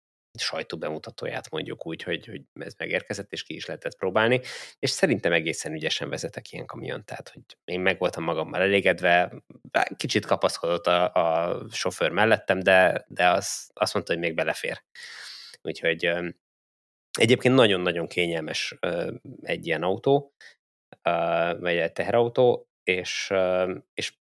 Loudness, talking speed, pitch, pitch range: -25 LUFS, 130 wpm, 90 Hz, 85-100 Hz